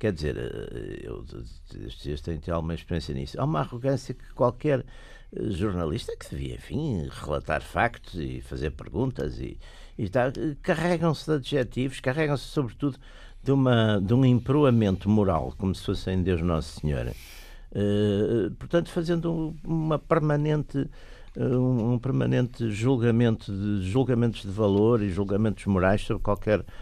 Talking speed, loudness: 140 wpm, -27 LUFS